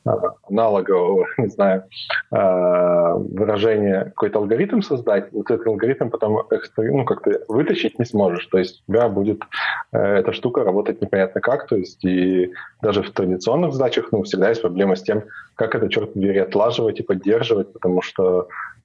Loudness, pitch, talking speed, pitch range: -20 LUFS, 95 Hz, 155 wpm, 90-105 Hz